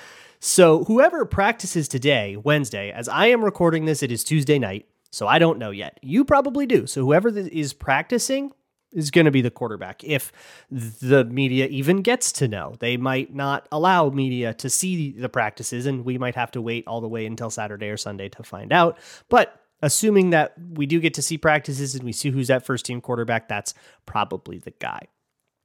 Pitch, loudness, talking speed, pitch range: 135 Hz, -21 LUFS, 200 wpm, 120-165 Hz